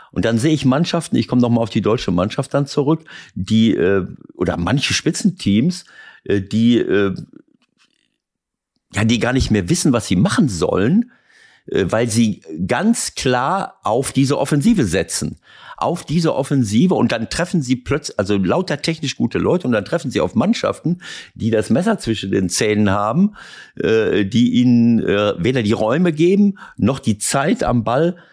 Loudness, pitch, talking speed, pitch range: -17 LUFS, 125 Hz, 155 wpm, 110-165 Hz